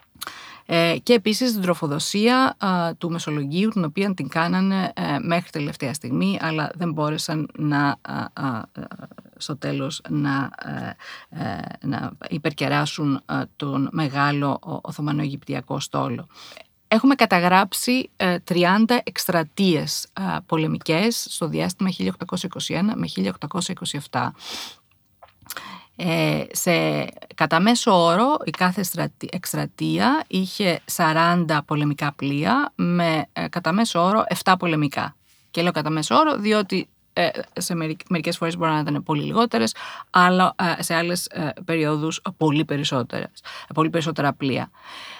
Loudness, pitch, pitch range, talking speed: -22 LUFS, 165 Hz, 150-185 Hz, 110 wpm